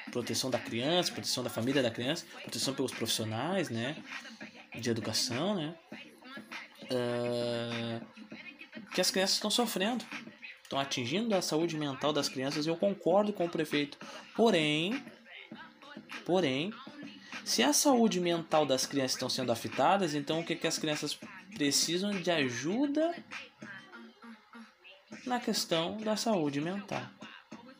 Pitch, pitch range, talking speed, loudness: 170 Hz, 135-220 Hz, 130 wpm, -32 LUFS